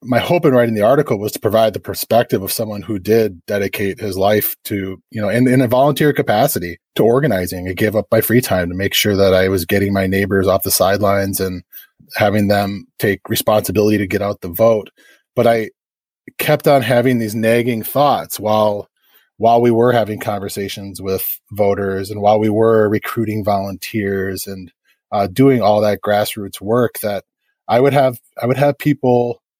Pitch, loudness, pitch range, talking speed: 105 Hz, -16 LUFS, 100-115 Hz, 190 wpm